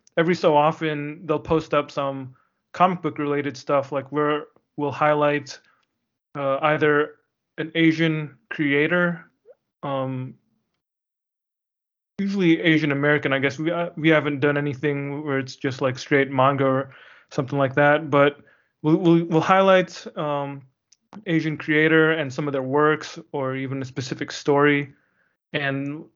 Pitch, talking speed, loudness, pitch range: 150 Hz, 140 wpm, -22 LUFS, 140-160 Hz